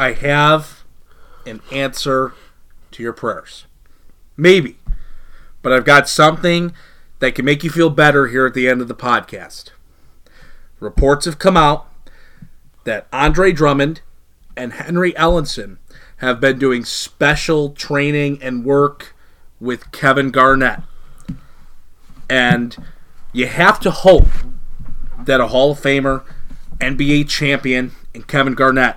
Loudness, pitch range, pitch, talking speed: -15 LUFS, 125-150 Hz, 135 Hz, 125 wpm